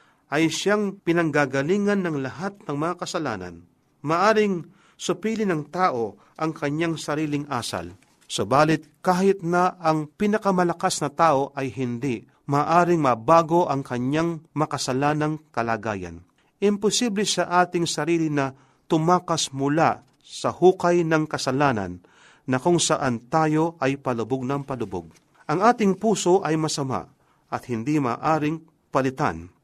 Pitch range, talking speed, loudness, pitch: 135-175 Hz, 120 wpm, -23 LUFS, 155 Hz